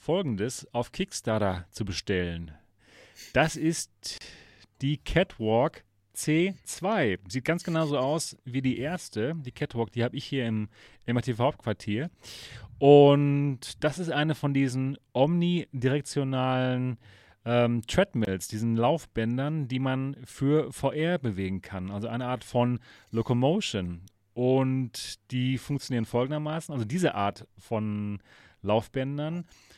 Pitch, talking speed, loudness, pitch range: 125 Hz, 115 wpm, -28 LUFS, 110-145 Hz